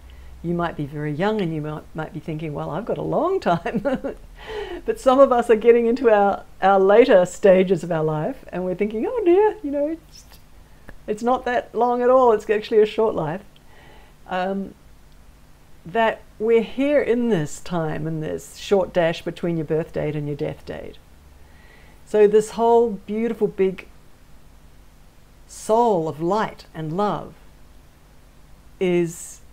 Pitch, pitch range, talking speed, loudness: 190 Hz, 155-230 Hz, 165 wpm, -21 LUFS